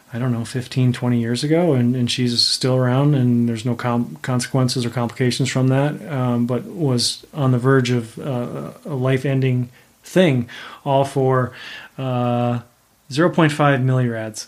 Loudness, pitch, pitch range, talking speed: -19 LUFS, 125 Hz, 120-135 Hz, 155 wpm